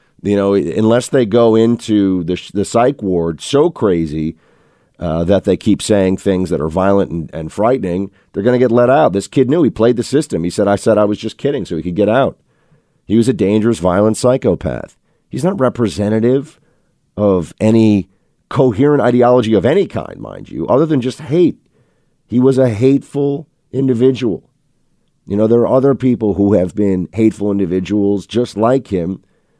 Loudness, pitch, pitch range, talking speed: -14 LUFS, 110 Hz, 95-125 Hz, 180 wpm